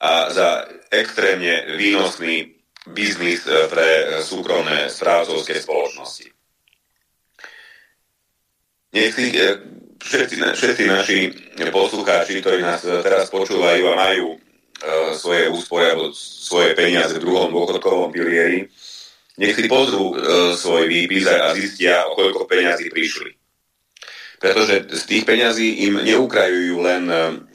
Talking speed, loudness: 115 wpm, -17 LUFS